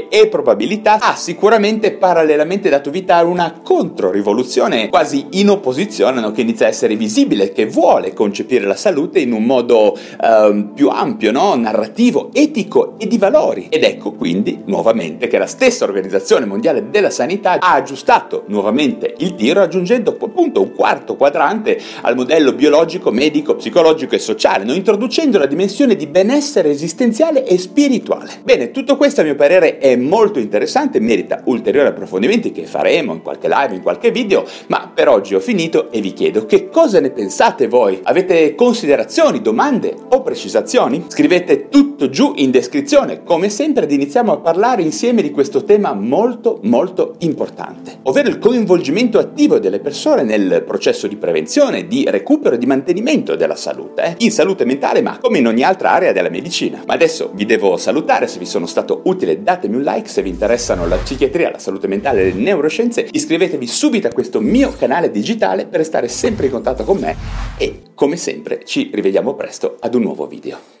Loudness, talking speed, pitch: -14 LUFS, 175 wpm, 280 Hz